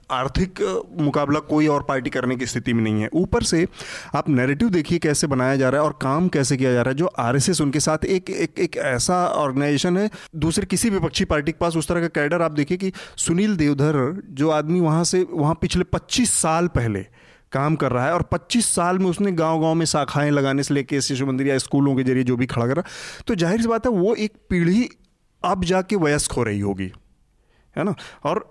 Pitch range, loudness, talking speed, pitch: 135-180 Hz, -21 LUFS, 225 wpm, 155 Hz